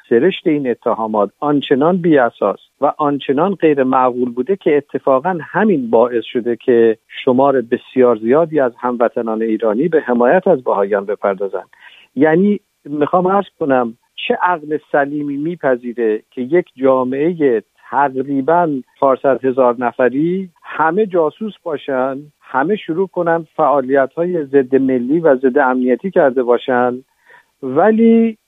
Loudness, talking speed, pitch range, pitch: -15 LUFS, 120 wpm, 125-165 Hz, 140 Hz